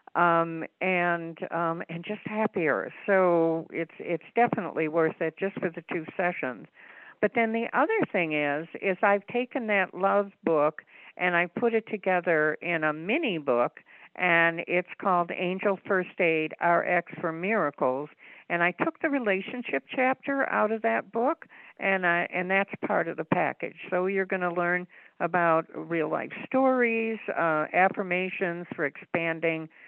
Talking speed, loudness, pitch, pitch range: 155 wpm, -27 LUFS, 180 Hz, 165-205 Hz